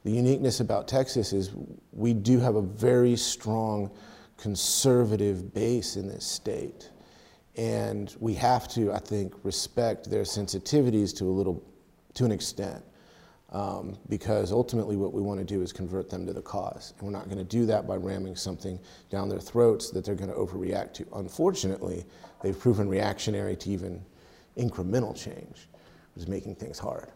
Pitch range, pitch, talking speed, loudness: 95-115 Hz, 100 Hz, 165 wpm, -29 LUFS